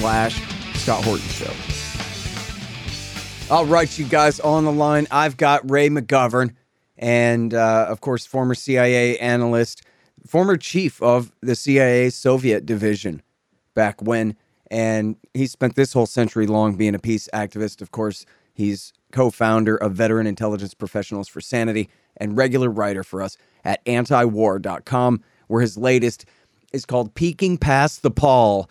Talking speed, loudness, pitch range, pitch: 140 wpm, -20 LUFS, 105-130 Hz, 115 Hz